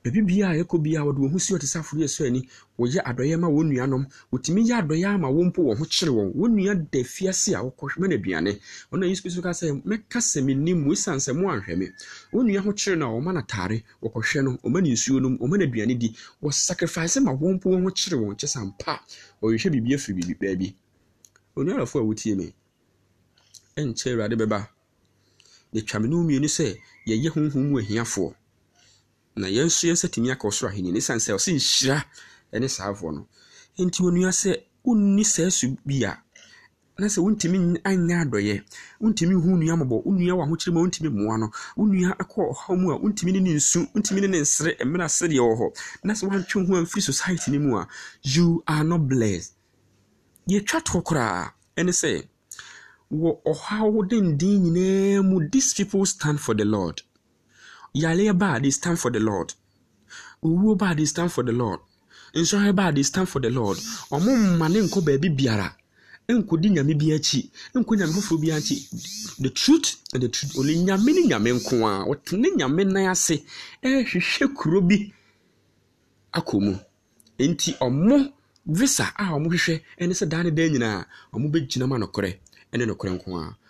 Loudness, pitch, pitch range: -23 LUFS, 155 Hz, 115-185 Hz